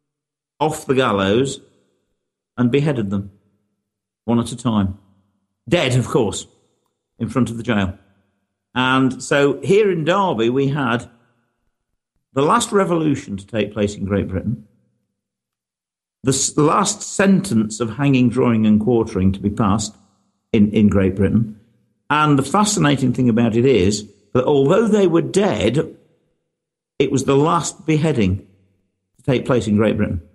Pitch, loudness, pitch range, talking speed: 115 Hz, -18 LUFS, 100-140 Hz, 140 wpm